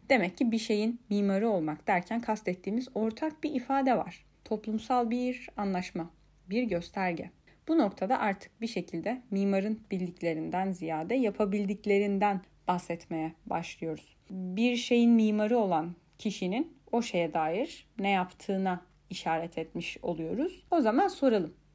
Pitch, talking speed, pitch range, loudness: 205 Hz, 120 wpm, 180-235 Hz, -31 LUFS